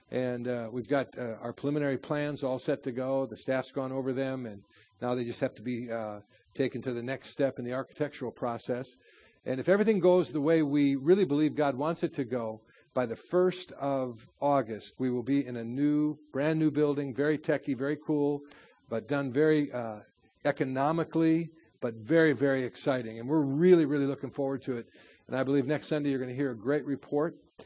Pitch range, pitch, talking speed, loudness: 125-150 Hz, 135 Hz, 205 wpm, -30 LUFS